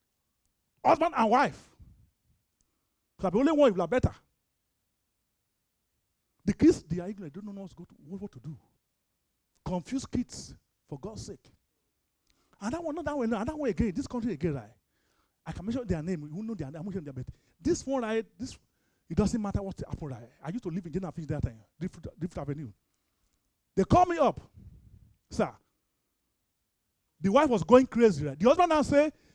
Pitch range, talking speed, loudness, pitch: 155-250 Hz, 195 wpm, -29 LUFS, 195 Hz